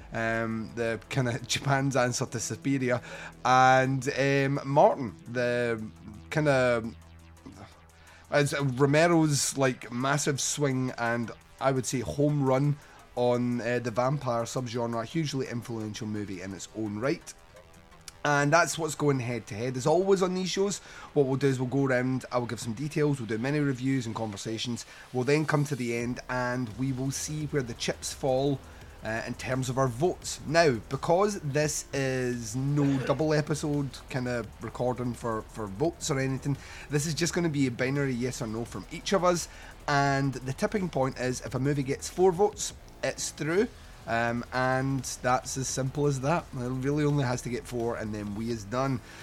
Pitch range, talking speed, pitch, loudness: 115-145 Hz, 185 wpm, 130 Hz, -29 LUFS